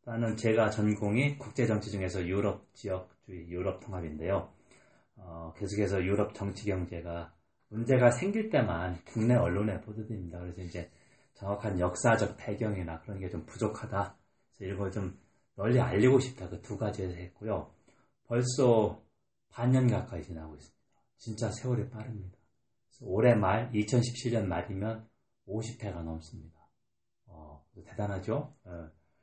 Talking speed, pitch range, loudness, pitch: 300 characters per minute, 90-115 Hz, -32 LUFS, 105 Hz